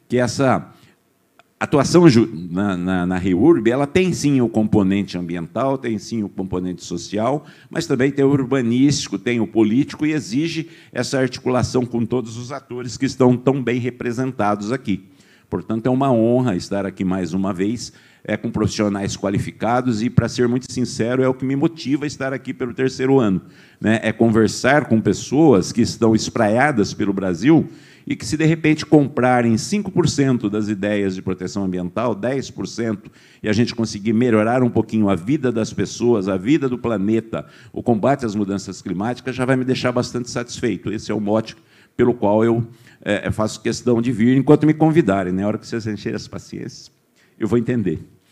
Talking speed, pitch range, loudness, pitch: 180 wpm, 105-130 Hz, -19 LUFS, 115 Hz